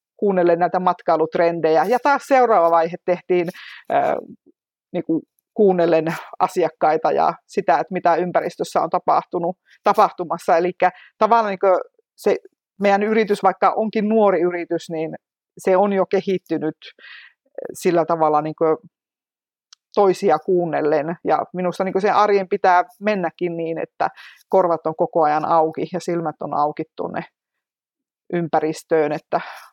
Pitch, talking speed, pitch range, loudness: 180 Hz, 125 wpm, 165-205 Hz, -19 LUFS